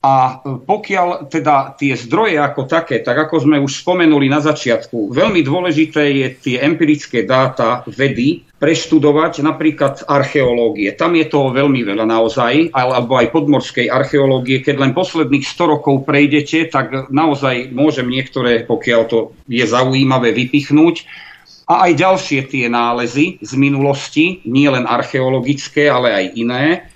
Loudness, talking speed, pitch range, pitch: -14 LUFS, 140 wpm, 130-155 Hz, 140 Hz